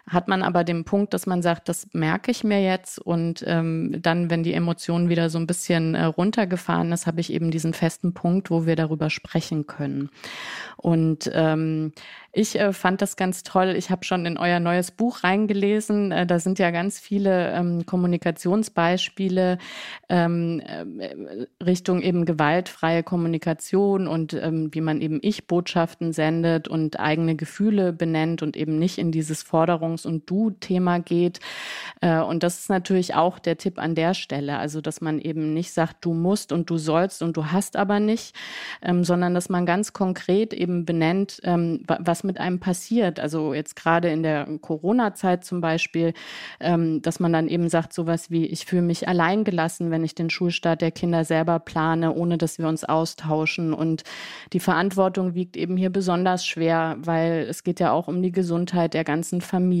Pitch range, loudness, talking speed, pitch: 165-185 Hz, -23 LUFS, 175 wpm, 170 Hz